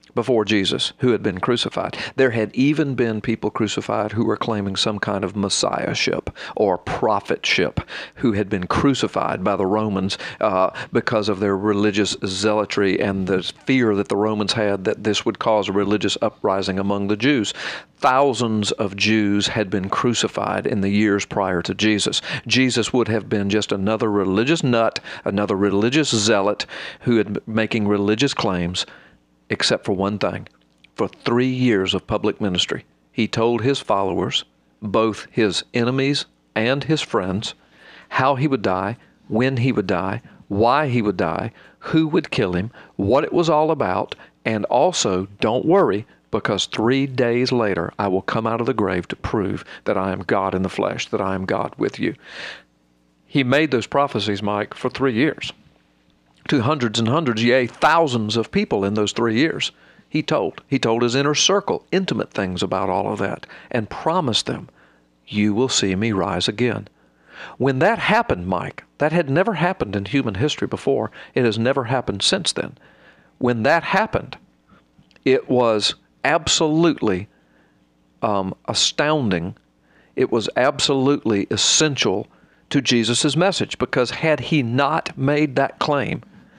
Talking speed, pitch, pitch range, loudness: 160 wpm, 110 Hz, 100-130 Hz, -20 LUFS